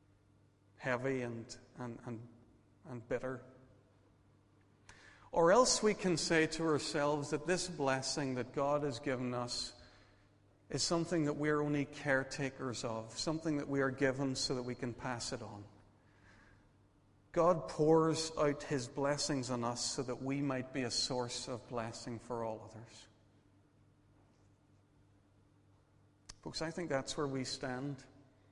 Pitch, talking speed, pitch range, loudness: 125 Hz, 140 wpm, 105-140 Hz, -36 LUFS